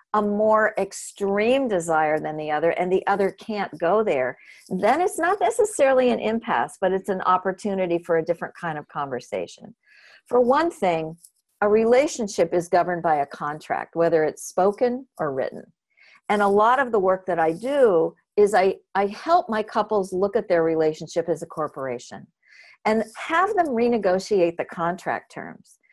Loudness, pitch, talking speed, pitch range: -23 LUFS, 195 Hz, 170 wpm, 170-240 Hz